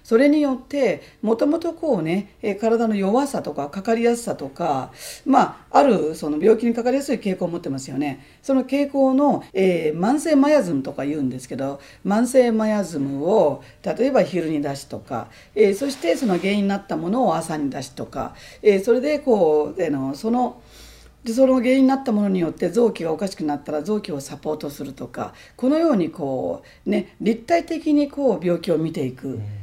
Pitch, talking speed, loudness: 205 Hz, 365 characters per minute, -21 LUFS